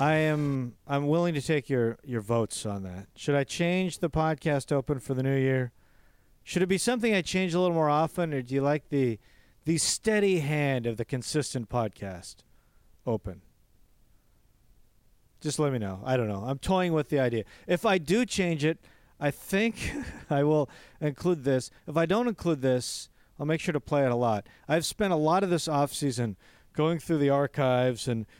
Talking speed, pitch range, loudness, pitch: 195 wpm, 120-165 Hz, -28 LUFS, 140 Hz